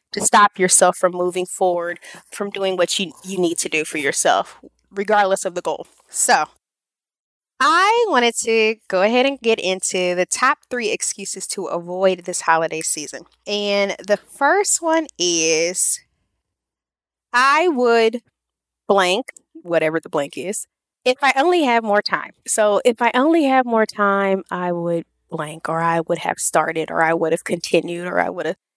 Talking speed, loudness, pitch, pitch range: 165 wpm, -18 LUFS, 195 Hz, 175-230 Hz